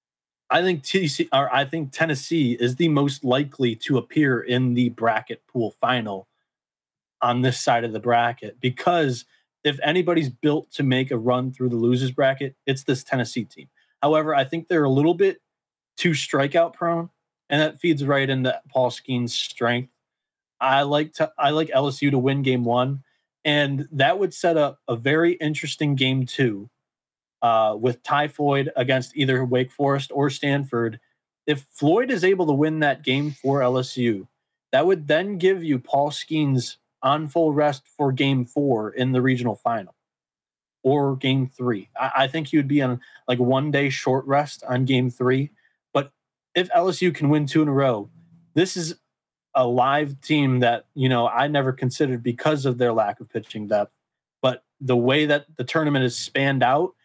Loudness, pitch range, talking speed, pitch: -22 LUFS, 125-150 Hz, 180 wpm, 135 Hz